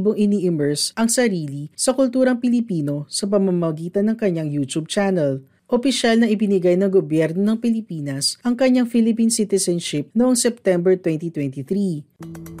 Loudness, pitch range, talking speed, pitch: -19 LUFS, 160-230 Hz, 130 wpm, 190 Hz